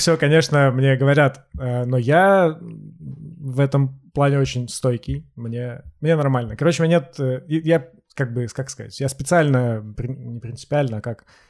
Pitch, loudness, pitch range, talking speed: 135 Hz, -20 LUFS, 125-155 Hz, 150 wpm